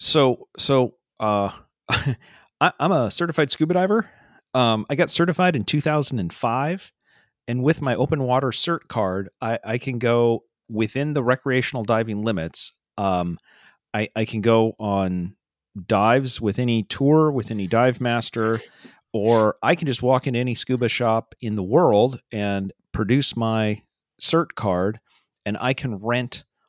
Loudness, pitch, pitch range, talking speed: -22 LUFS, 120 Hz, 110-135 Hz, 155 wpm